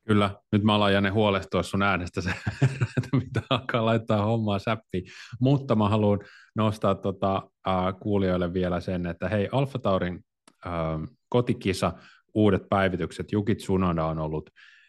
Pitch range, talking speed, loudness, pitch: 95-110 Hz, 140 wpm, -26 LUFS, 100 Hz